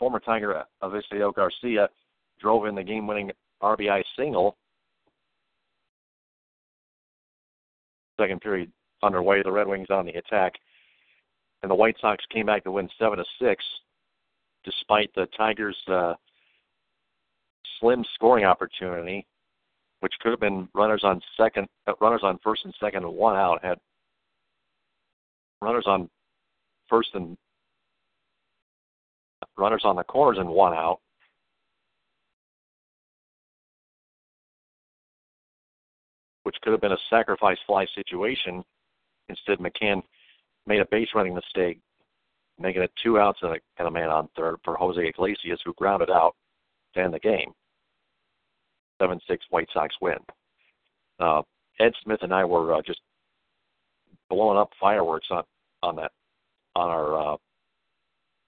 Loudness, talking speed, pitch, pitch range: -25 LUFS, 125 wpm, 100 Hz, 90-110 Hz